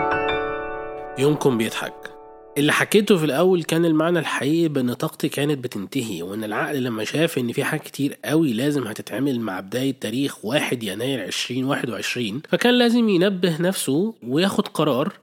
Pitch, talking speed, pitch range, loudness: 150 Hz, 140 wpm, 135-165 Hz, -22 LUFS